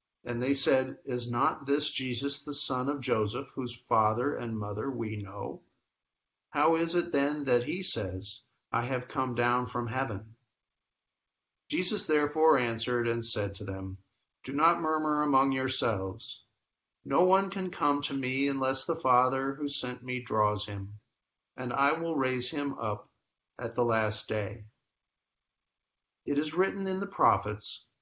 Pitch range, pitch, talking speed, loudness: 110-145 Hz, 125 Hz, 155 wpm, -30 LUFS